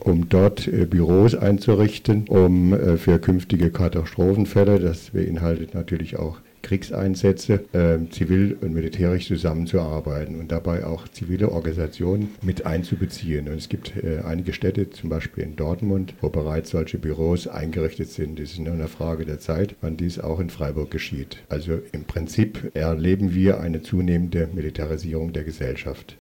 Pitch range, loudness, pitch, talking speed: 80-95 Hz, -23 LUFS, 85 Hz, 140 wpm